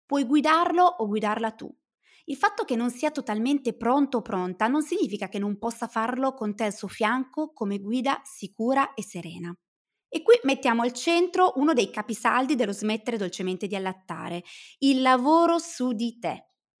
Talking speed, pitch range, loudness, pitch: 170 wpm, 210-285 Hz, -25 LUFS, 240 Hz